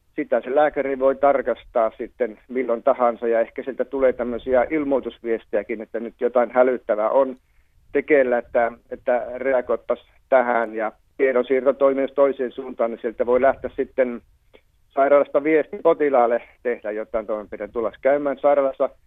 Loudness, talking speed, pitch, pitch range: -21 LUFS, 130 wpm, 125 Hz, 115-135 Hz